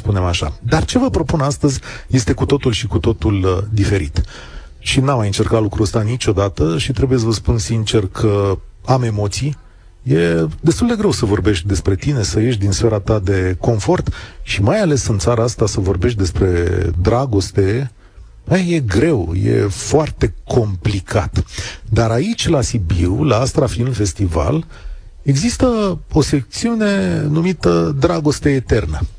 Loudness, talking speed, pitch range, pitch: -16 LUFS, 150 wpm, 100-135 Hz, 115 Hz